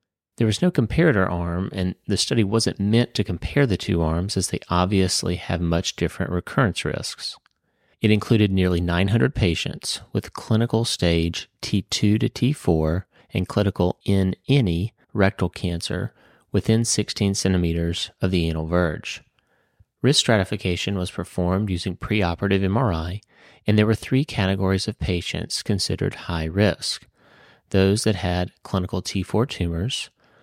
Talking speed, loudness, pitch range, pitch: 140 wpm, -23 LUFS, 90-110 Hz, 95 Hz